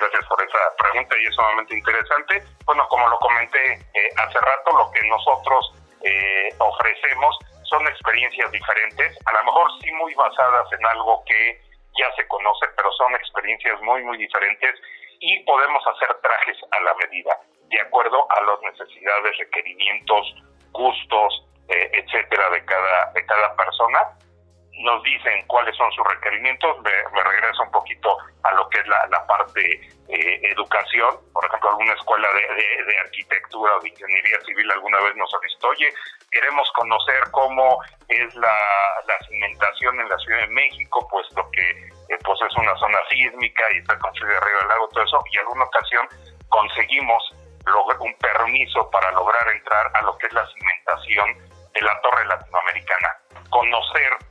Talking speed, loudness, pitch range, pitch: 165 wpm, -19 LUFS, 85-135 Hz, 100 Hz